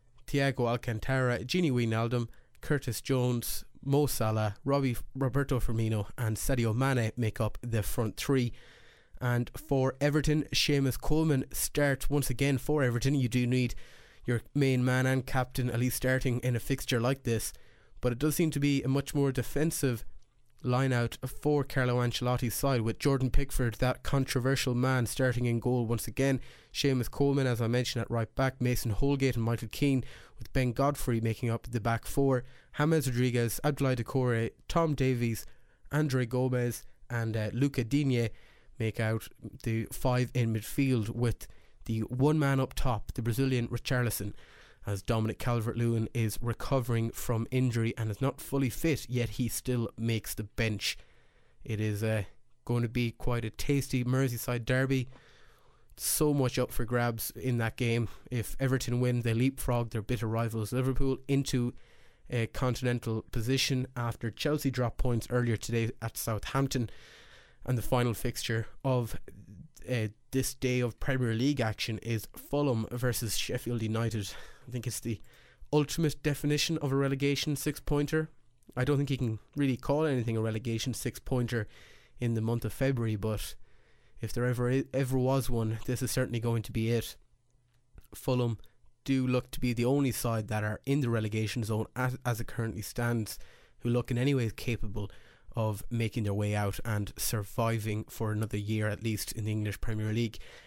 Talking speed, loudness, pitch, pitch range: 165 wpm, -31 LUFS, 120 Hz, 115-130 Hz